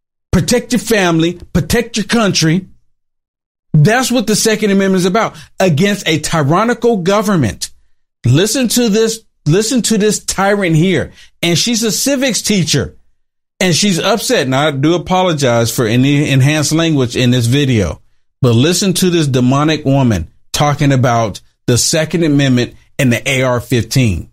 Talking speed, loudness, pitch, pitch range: 145 wpm, -13 LUFS, 160 Hz, 130-205 Hz